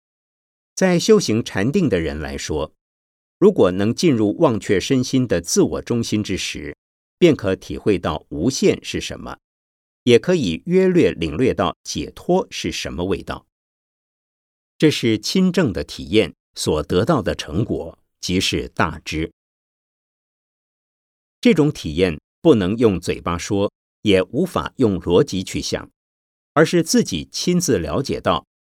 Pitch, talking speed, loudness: 100 Hz, 195 characters per minute, -19 LUFS